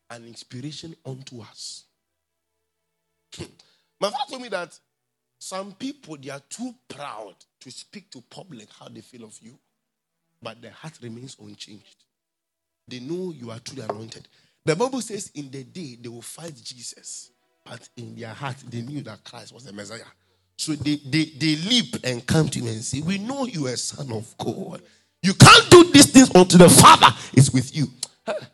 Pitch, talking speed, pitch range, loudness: 130 Hz, 180 wpm, 115-170 Hz, -15 LUFS